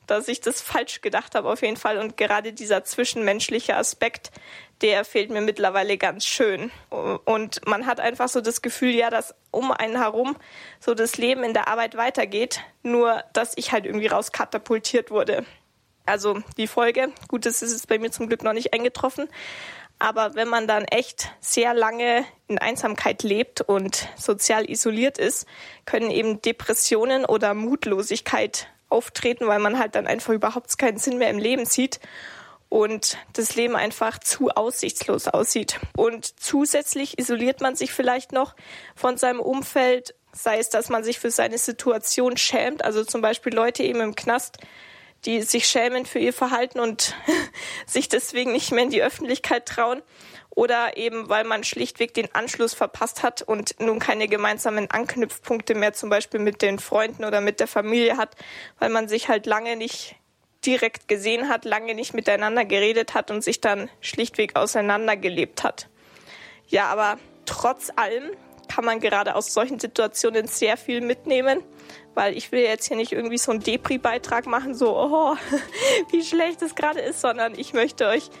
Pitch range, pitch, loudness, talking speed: 220-250 Hz, 230 Hz, -23 LUFS, 170 wpm